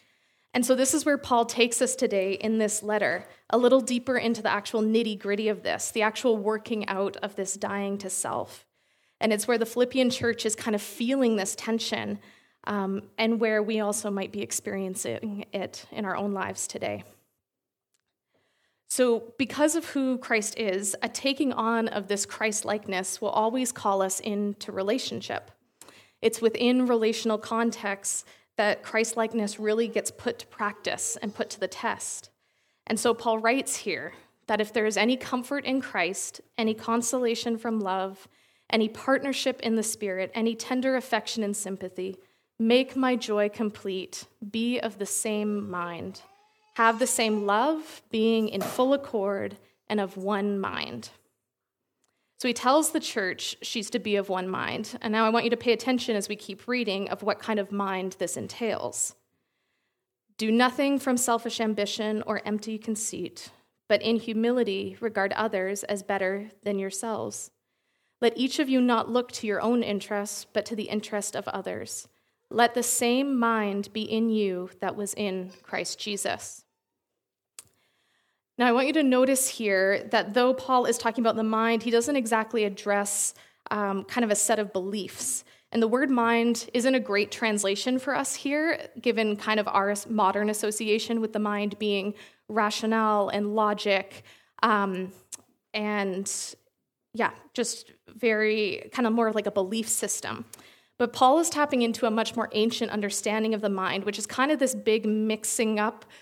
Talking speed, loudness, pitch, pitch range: 170 wpm, -27 LUFS, 220 Hz, 205-240 Hz